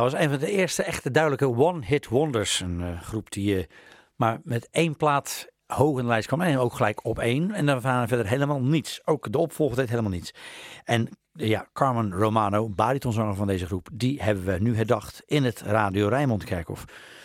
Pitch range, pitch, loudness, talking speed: 105-145 Hz, 120 Hz, -25 LUFS, 200 wpm